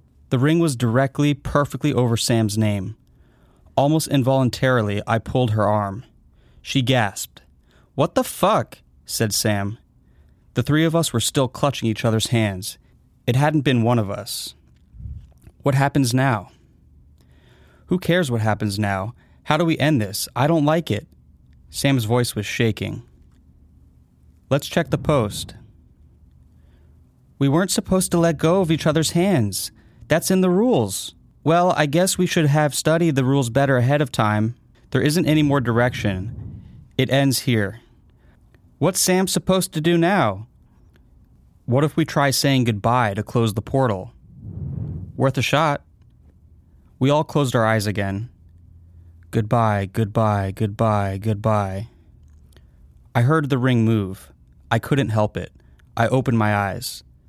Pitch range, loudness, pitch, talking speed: 100-140 Hz, -20 LUFS, 115 Hz, 145 wpm